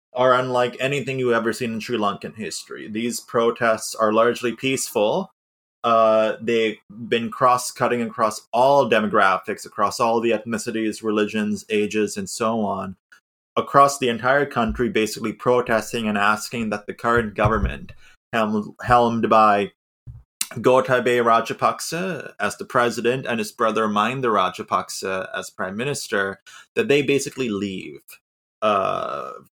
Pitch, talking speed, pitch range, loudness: 115 Hz, 130 wpm, 110-125 Hz, -21 LUFS